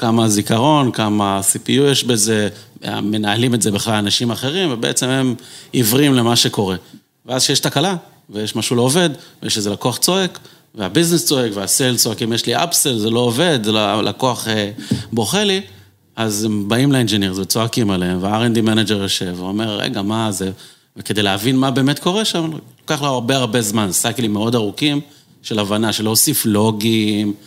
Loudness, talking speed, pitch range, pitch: -16 LUFS, 165 wpm, 105-135 Hz, 115 Hz